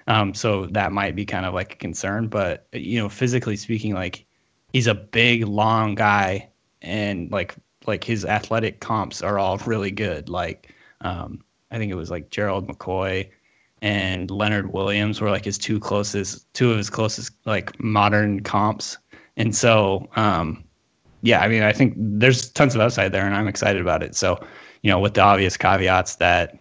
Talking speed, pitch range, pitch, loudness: 185 wpm, 95-110 Hz, 105 Hz, -21 LUFS